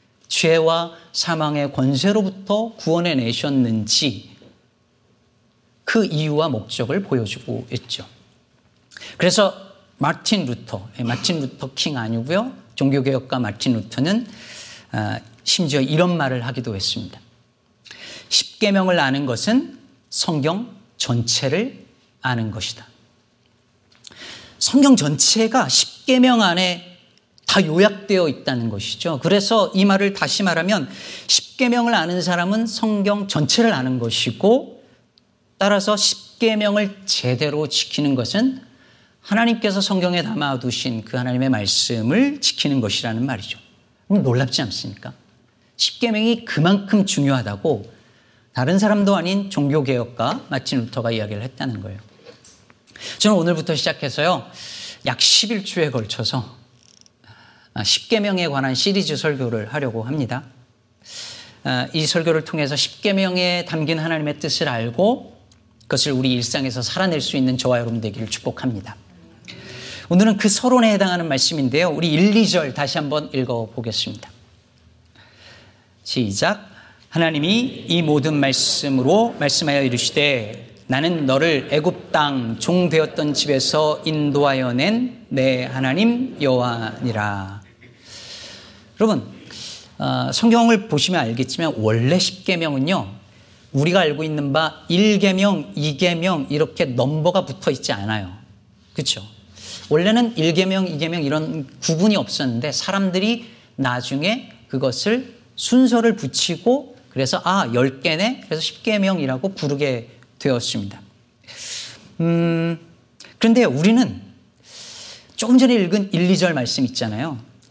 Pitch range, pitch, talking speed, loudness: 120-190 Hz, 145 Hz, 260 characters per minute, -19 LUFS